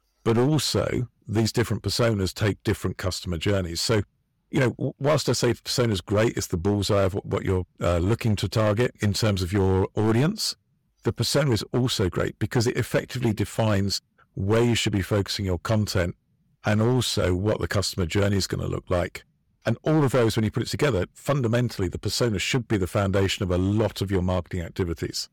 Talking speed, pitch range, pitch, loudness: 195 wpm, 95-120 Hz, 110 Hz, -25 LUFS